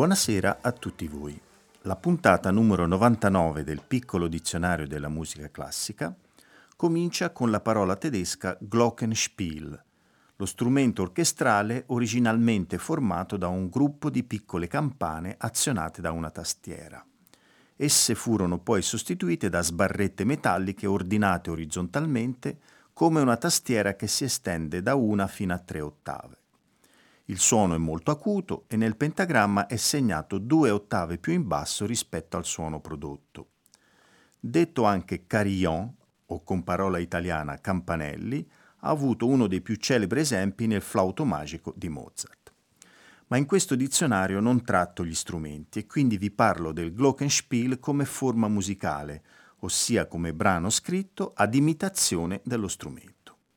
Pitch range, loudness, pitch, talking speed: 85-125 Hz, -26 LUFS, 100 Hz, 135 wpm